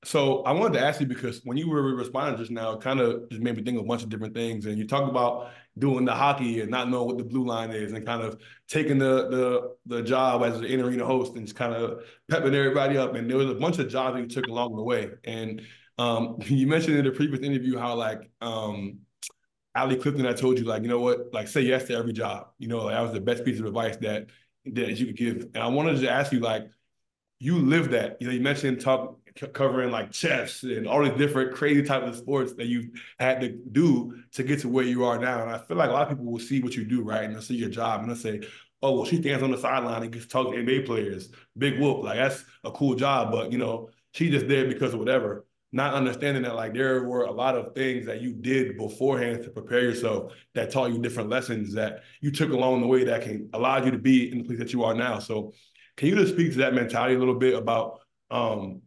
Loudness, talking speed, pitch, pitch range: -26 LUFS, 265 wpm, 125 Hz, 115-130 Hz